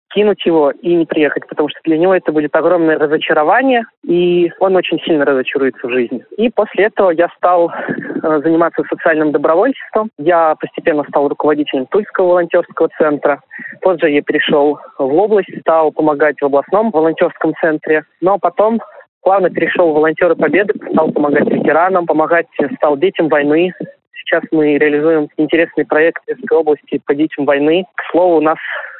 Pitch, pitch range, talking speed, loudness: 165 Hz, 155-180 Hz, 155 wpm, -13 LUFS